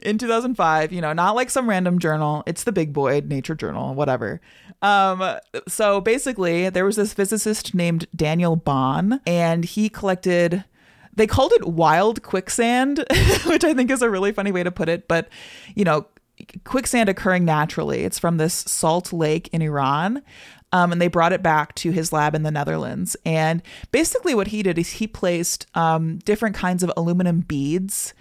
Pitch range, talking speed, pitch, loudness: 160-210 Hz, 180 wpm, 180 Hz, -21 LUFS